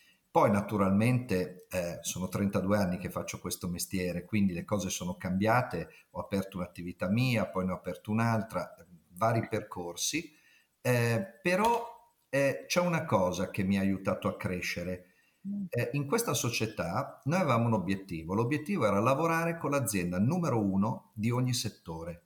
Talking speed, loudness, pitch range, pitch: 150 wpm, -31 LUFS, 90-125 Hz, 105 Hz